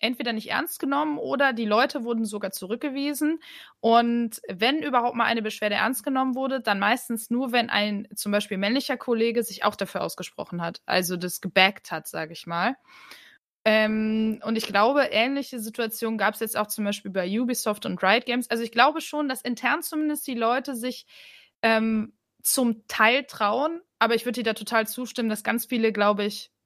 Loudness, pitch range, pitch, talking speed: -25 LUFS, 210-260 Hz, 230 Hz, 185 wpm